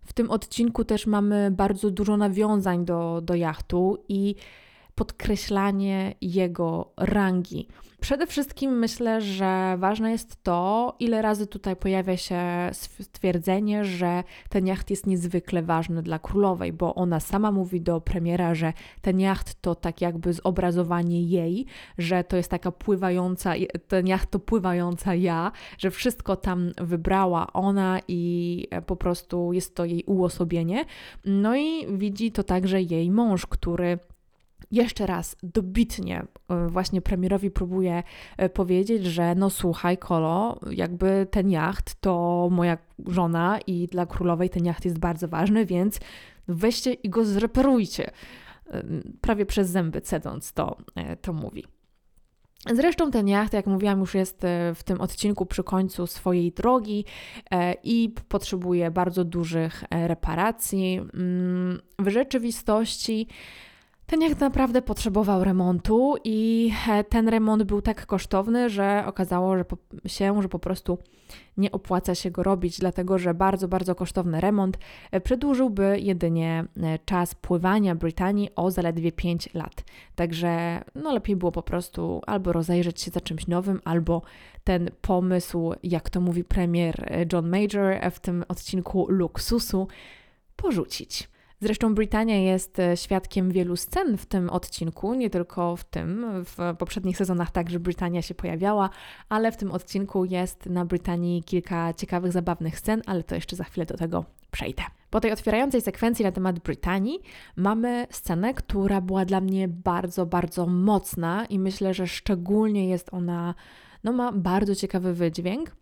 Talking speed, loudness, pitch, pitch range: 140 wpm, -26 LUFS, 185 Hz, 175-205 Hz